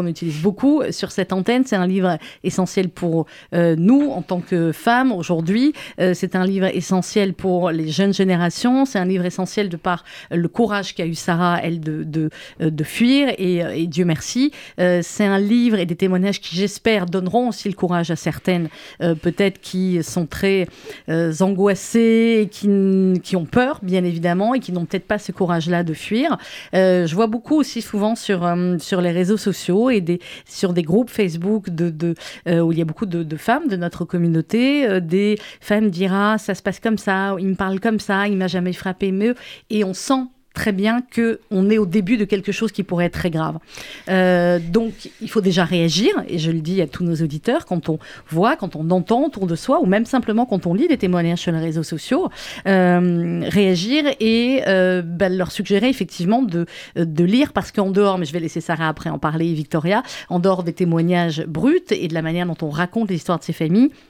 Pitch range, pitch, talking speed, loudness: 175-215 Hz, 185 Hz, 215 wpm, -19 LUFS